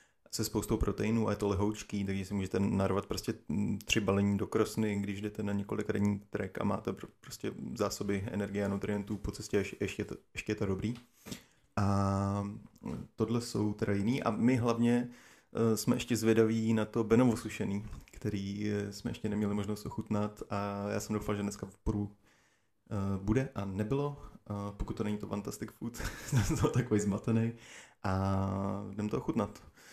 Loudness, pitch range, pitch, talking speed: -34 LUFS, 100-110 Hz, 105 Hz, 175 wpm